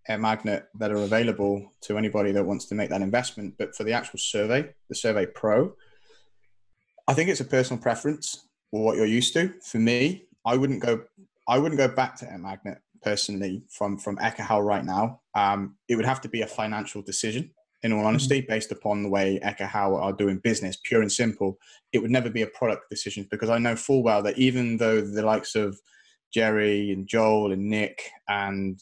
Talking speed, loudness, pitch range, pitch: 205 wpm, -26 LUFS, 100-120 Hz, 110 Hz